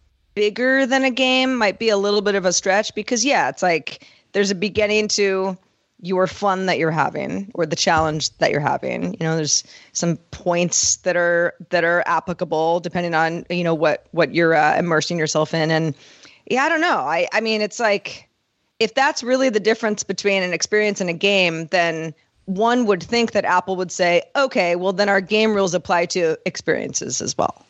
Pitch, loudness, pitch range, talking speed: 190 Hz, -19 LUFS, 170-215 Hz, 200 wpm